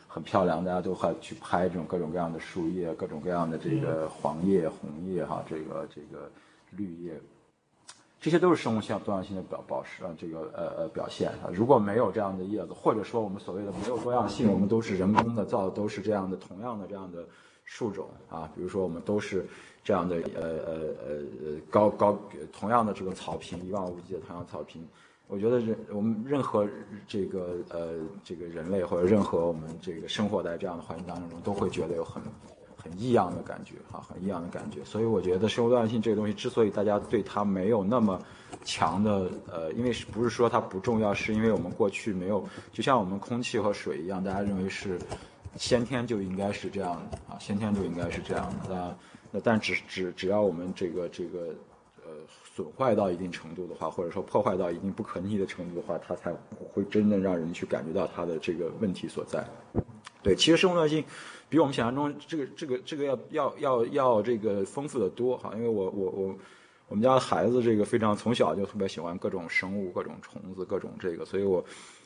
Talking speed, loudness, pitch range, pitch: 325 characters per minute, -30 LUFS, 90-115 Hz, 100 Hz